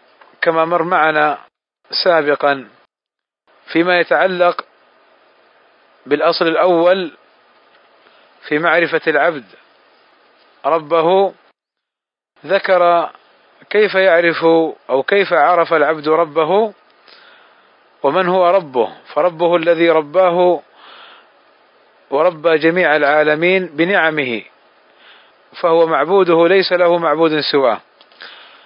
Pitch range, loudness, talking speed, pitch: 155-180 Hz, -14 LUFS, 75 wpm, 170 Hz